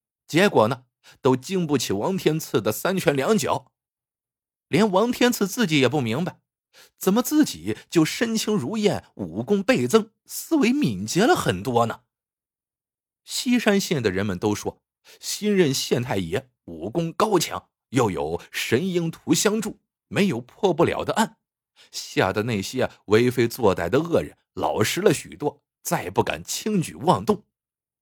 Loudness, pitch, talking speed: -23 LUFS, 185 Hz, 215 characters per minute